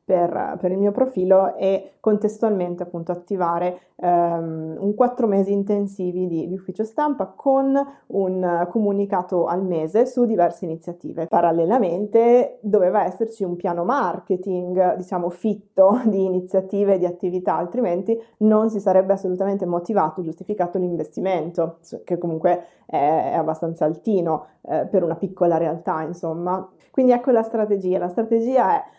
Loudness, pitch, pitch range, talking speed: -21 LUFS, 185 Hz, 175-215 Hz, 135 wpm